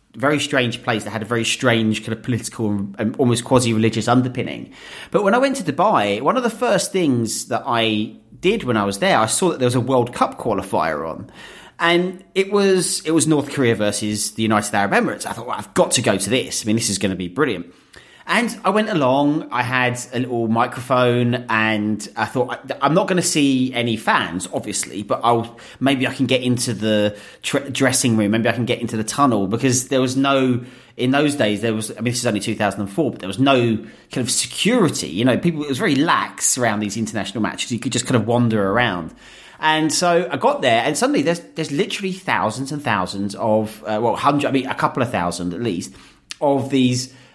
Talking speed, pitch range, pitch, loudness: 225 wpm, 110-140 Hz, 120 Hz, -19 LUFS